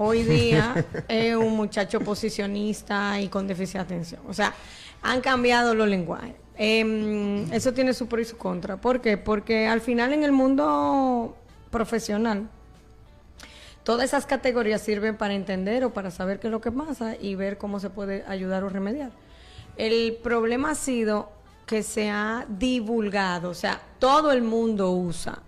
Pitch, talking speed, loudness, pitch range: 220 Hz, 165 wpm, -25 LUFS, 200-235 Hz